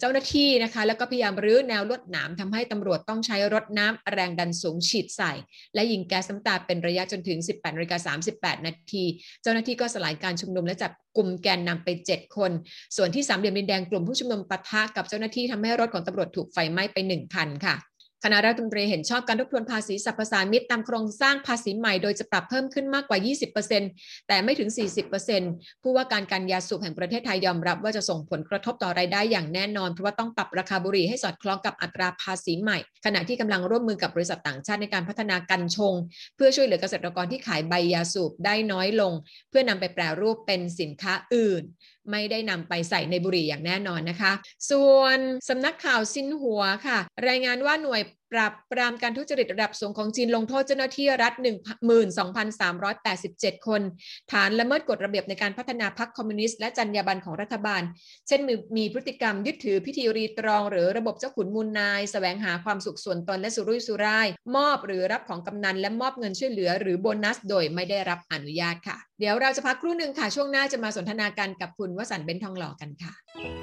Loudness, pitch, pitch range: -26 LUFS, 205 Hz, 185-230 Hz